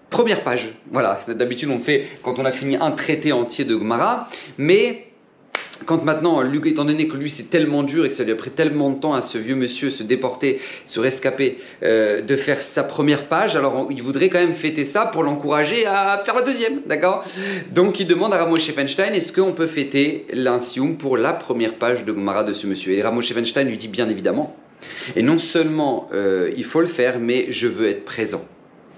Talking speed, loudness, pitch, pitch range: 215 wpm, -20 LUFS, 145 Hz, 125-165 Hz